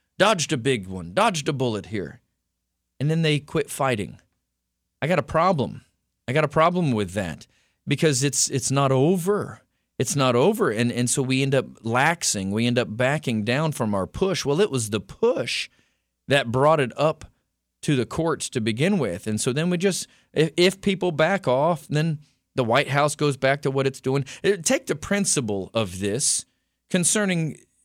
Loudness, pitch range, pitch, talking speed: -23 LUFS, 120-160 Hz, 140 Hz, 185 wpm